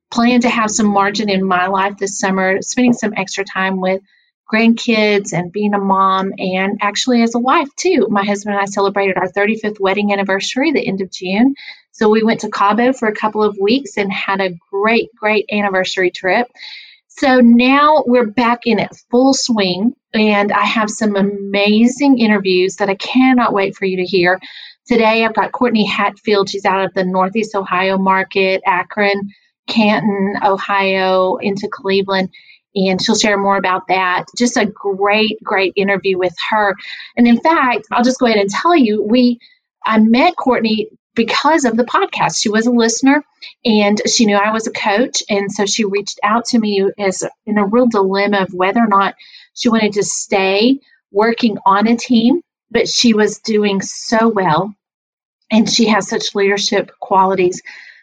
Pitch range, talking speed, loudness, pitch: 195-235 Hz, 180 wpm, -14 LUFS, 210 Hz